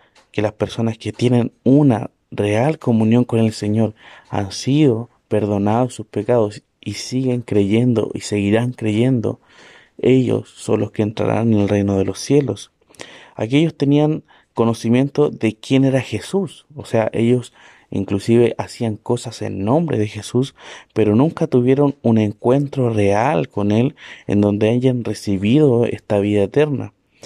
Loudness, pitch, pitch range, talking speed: -18 LUFS, 115 Hz, 105-130 Hz, 145 wpm